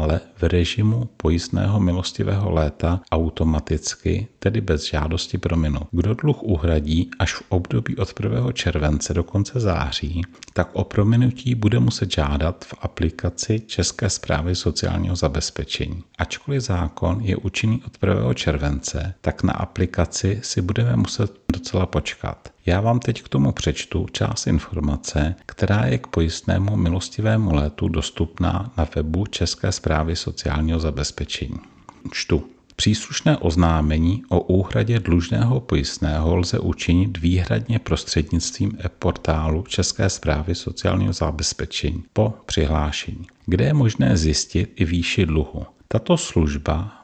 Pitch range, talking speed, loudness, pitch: 80-105 Hz, 125 wpm, -22 LUFS, 90 Hz